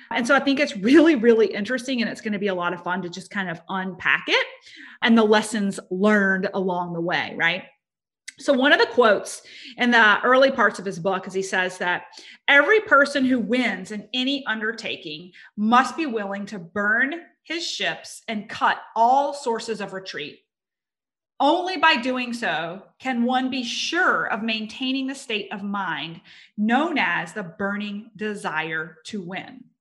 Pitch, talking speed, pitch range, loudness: 225 Hz, 175 wpm, 195-270 Hz, -22 LUFS